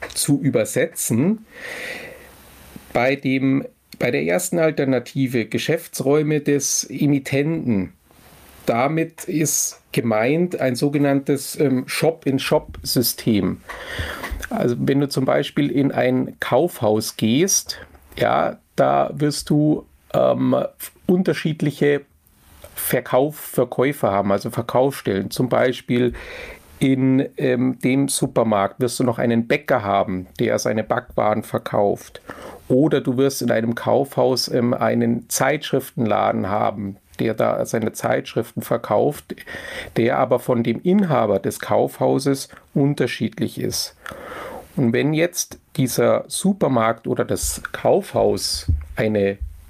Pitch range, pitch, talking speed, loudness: 110-145 Hz, 130 Hz, 105 wpm, -20 LUFS